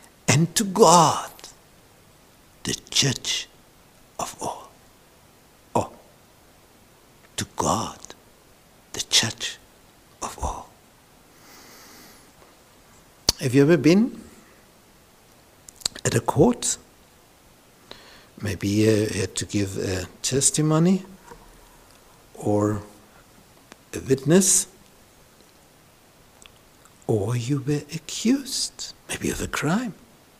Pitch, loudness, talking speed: 140 Hz, -22 LUFS, 75 wpm